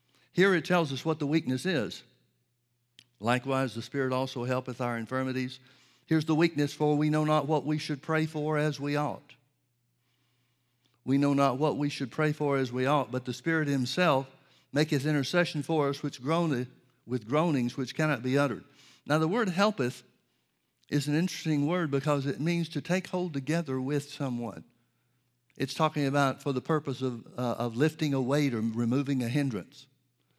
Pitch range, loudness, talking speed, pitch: 125-155 Hz, -29 LUFS, 180 wpm, 140 Hz